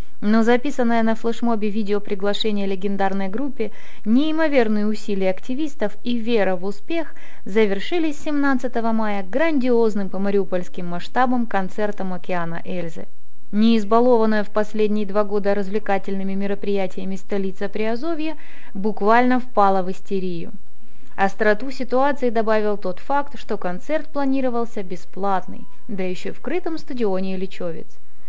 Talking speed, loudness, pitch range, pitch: 110 wpm, -22 LUFS, 195-245 Hz, 215 Hz